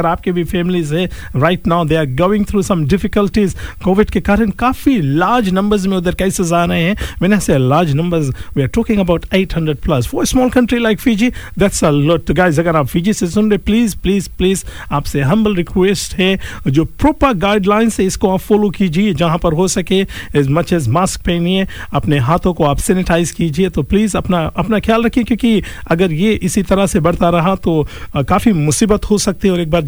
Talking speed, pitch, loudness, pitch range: 100 wpm, 185 Hz, -14 LUFS, 170-205 Hz